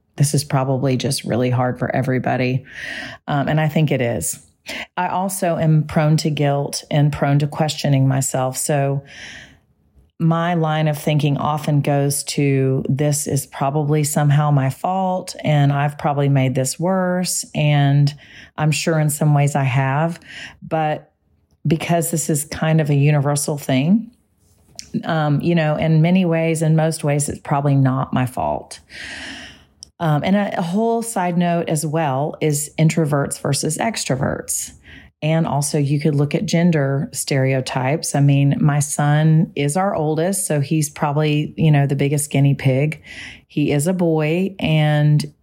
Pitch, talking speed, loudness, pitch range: 150 Hz, 155 wpm, -18 LUFS, 140-160 Hz